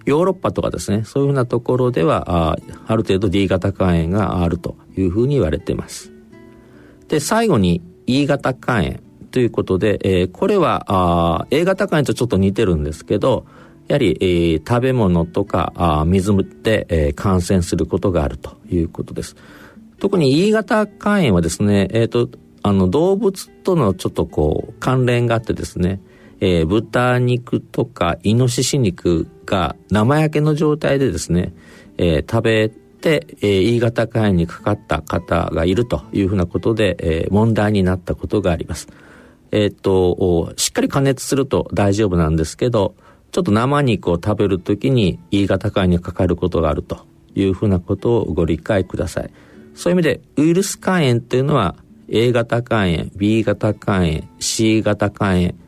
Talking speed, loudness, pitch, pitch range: 325 characters per minute, -18 LUFS, 100 Hz, 90-120 Hz